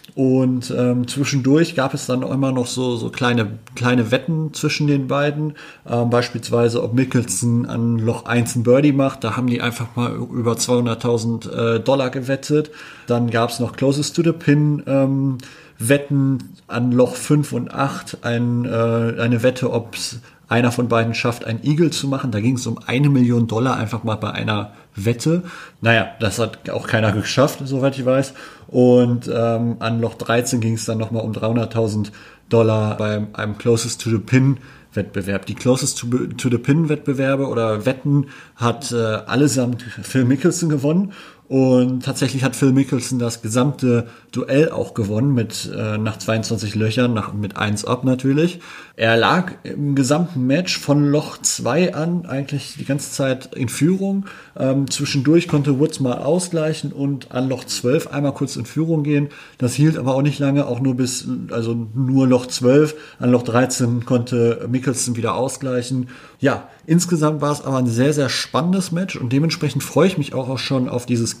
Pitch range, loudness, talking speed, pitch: 115-140 Hz, -19 LUFS, 175 wpm, 125 Hz